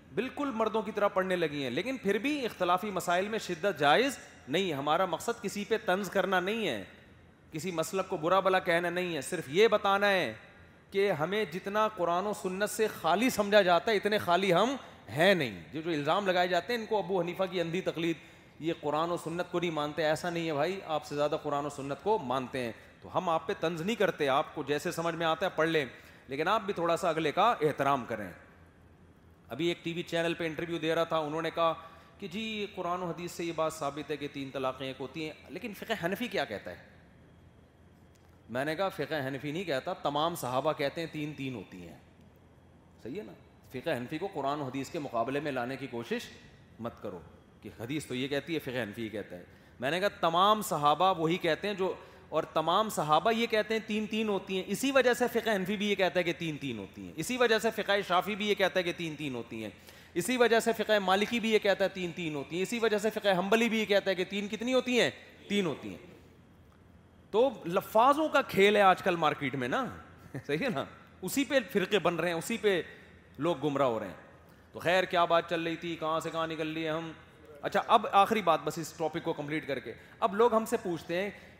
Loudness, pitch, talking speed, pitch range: -31 LUFS, 170 Hz, 235 wpm, 145-200 Hz